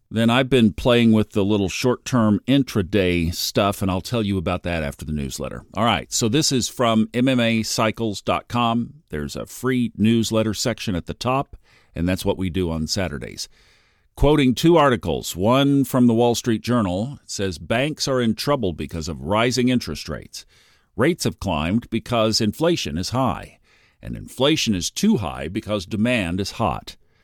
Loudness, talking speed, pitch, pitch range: -21 LUFS, 170 wpm, 110 Hz, 90-125 Hz